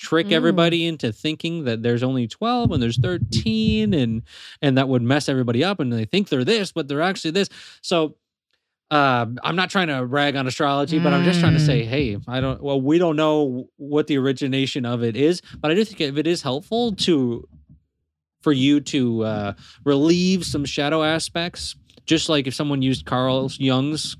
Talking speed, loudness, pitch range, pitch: 195 wpm, -21 LUFS, 125-160 Hz, 145 Hz